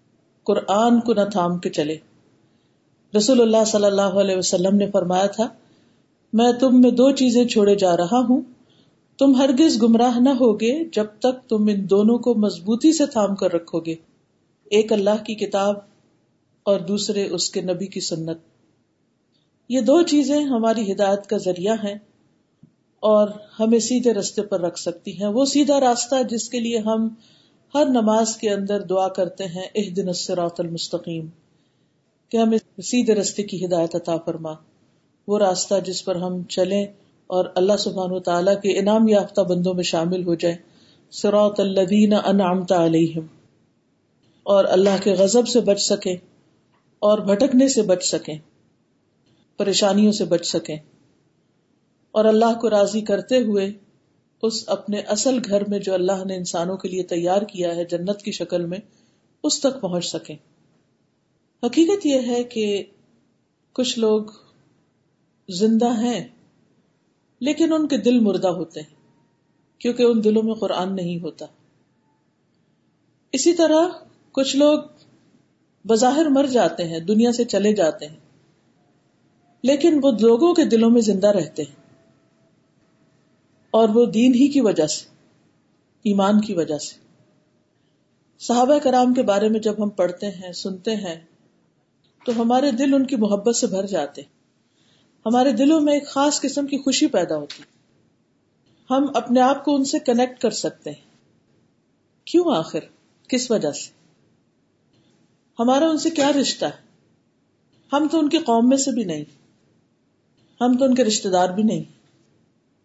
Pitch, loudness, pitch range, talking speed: 210 Hz, -20 LUFS, 185-245 Hz, 150 wpm